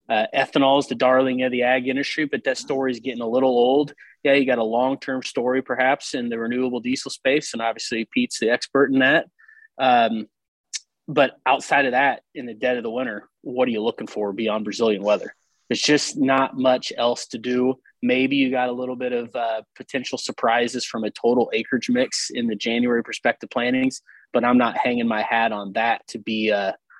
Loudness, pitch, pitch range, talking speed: -22 LUFS, 125 Hz, 115-130 Hz, 210 wpm